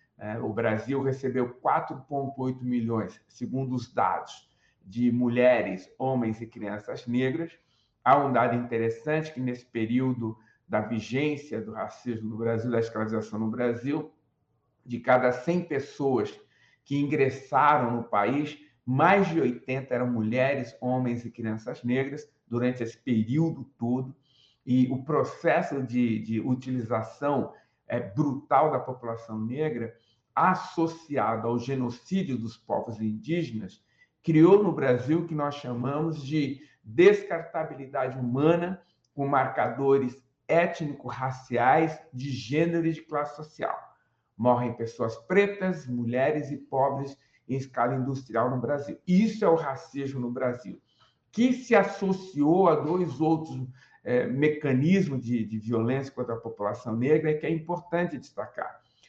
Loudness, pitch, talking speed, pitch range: -27 LUFS, 130 Hz, 125 wpm, 120-150 Hz